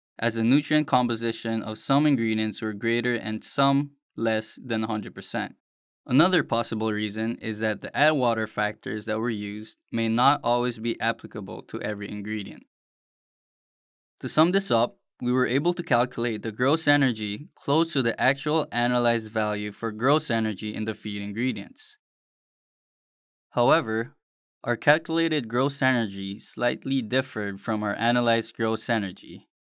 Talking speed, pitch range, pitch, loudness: 145 wpm, 110-135 Hz, 115 Hz, -25 LUFS